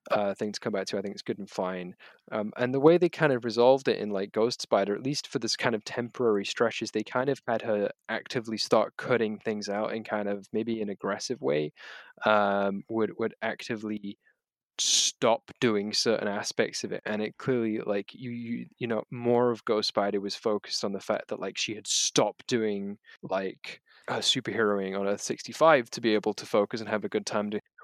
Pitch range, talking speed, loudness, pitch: 100-120 Hz, 220 wpm, -28 LUFS, 105 Hz